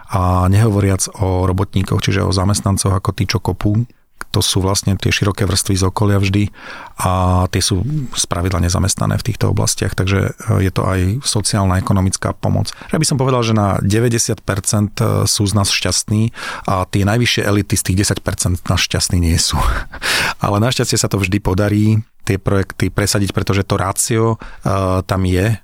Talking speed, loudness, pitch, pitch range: 170 wpm, -16 LUFS, 100 Hz, 95-110 Hz